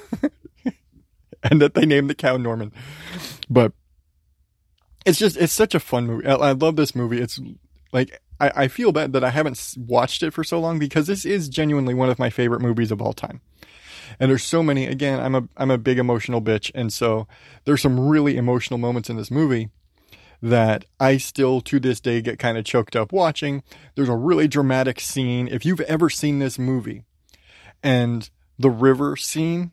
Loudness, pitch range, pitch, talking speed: -21 LUFS, 115-145 Hz, 130 Hz, 190 wpm